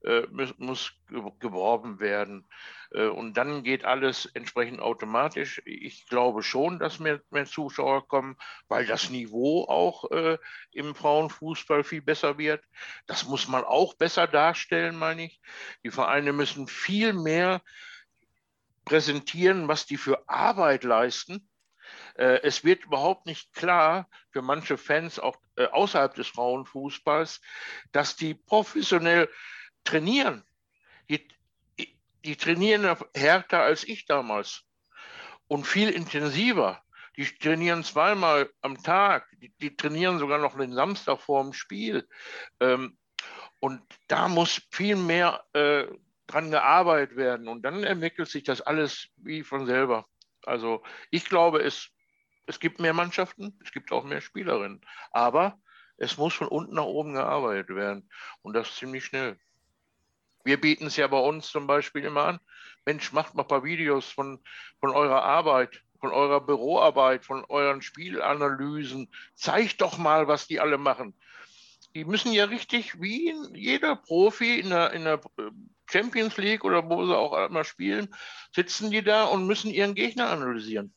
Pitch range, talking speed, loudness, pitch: 135-180 Hz, 140 wpm, -26 LUFS, 150 Hz